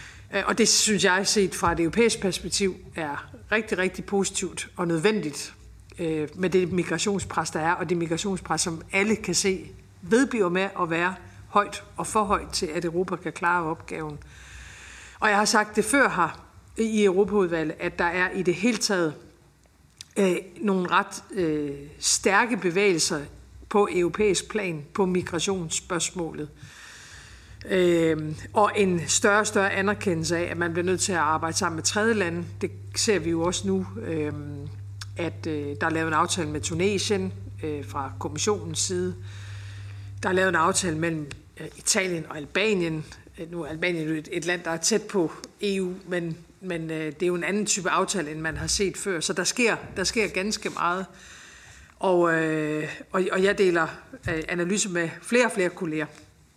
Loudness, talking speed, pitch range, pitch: -25 LUFS, 175 wpm, 155-195 Hz, 175 Hz